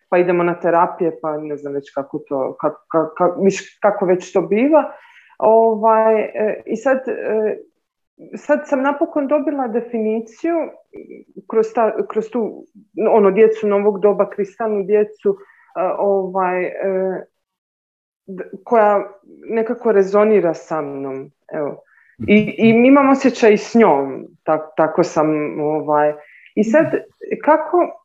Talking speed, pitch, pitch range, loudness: 115 wpm, 210 Hz, 175-240 Hz, -17 LUFS